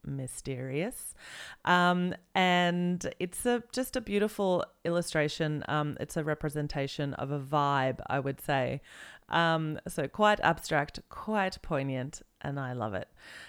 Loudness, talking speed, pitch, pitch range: -31 LUFS, 130 wpm, 155 Hz, 140-180 Hz